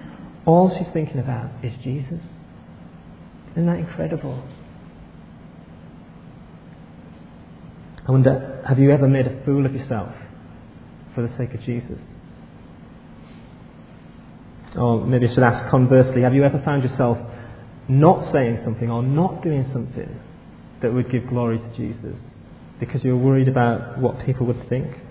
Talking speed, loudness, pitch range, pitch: 135 wpm, -20 LUFS, 120-135 Hz, 125 Hz